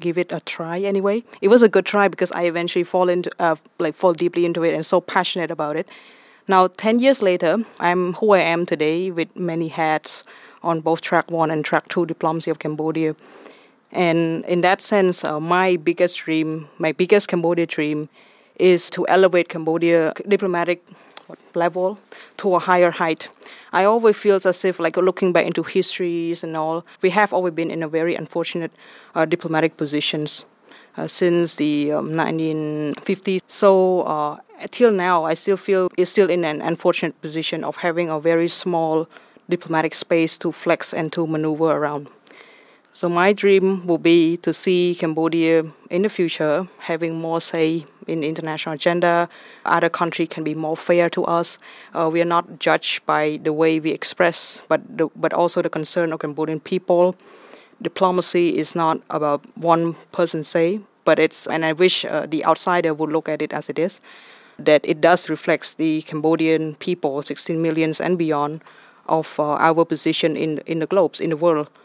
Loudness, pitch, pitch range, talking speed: -20 LUFS, 170 Hz, 160-180 Hz, 180 wpm